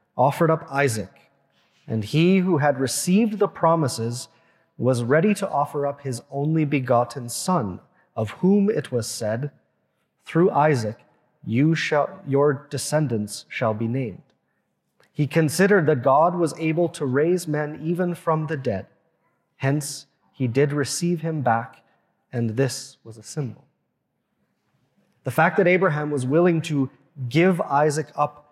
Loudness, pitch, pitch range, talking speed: -22 LUFS, 145 Hz, 130-165 Hz, 140 wpm